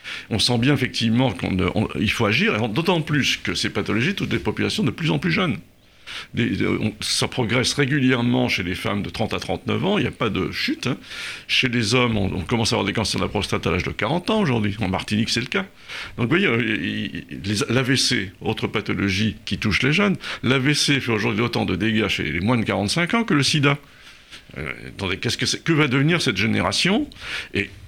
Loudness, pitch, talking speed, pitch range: -21 LUFS, 110 Hz, 225 wpm, 100-130 Hz